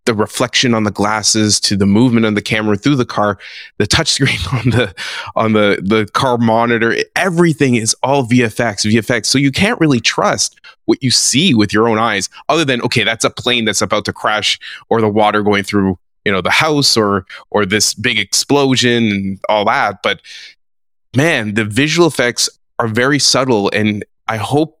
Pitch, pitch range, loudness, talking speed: 115 Hz, 105-130 Hz, -13 LUFS, 190 wpm